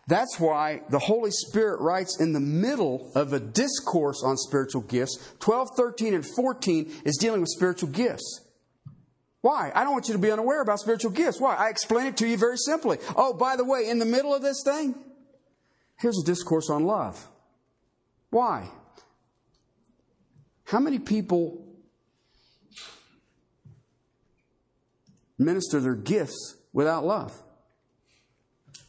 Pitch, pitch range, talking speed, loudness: 205 Hz, 150-245 Hz, 140 wpm, -26 LUFS